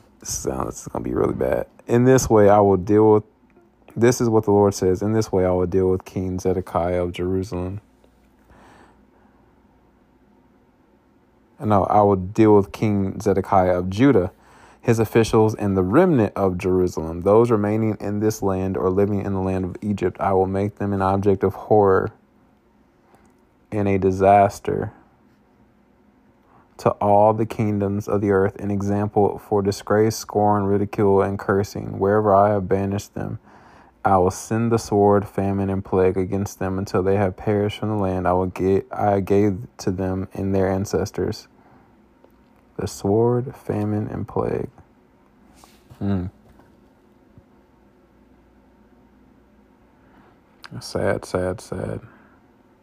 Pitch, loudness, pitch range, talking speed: 100 Hz, -20 LUFS, 95-105 Hz, 145 wpm